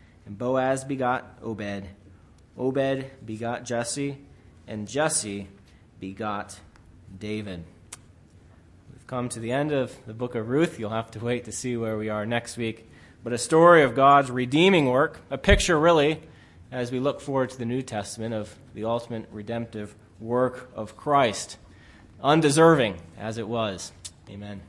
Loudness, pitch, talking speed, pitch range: -25 LUFS, 115 Hz, 150 wpm, 100-130 Hz